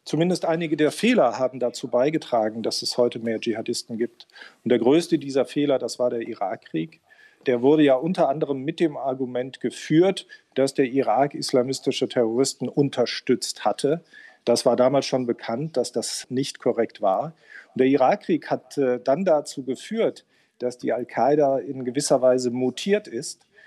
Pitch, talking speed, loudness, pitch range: 135 Hz, 160 wpm, -23 LUFS, 125-145 Hz